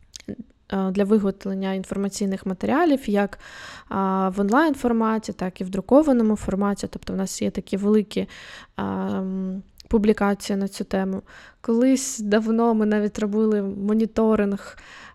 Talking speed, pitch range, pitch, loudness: 110 wpm, 195-220 Hz, 205 Hz, -23 LUFS